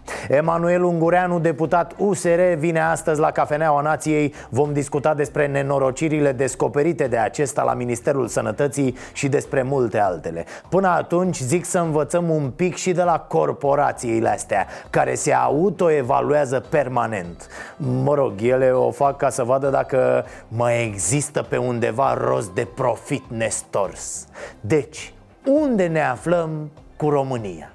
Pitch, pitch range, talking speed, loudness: 145 Hz, 125-160 Hz, 135 wpm, -20 LUFS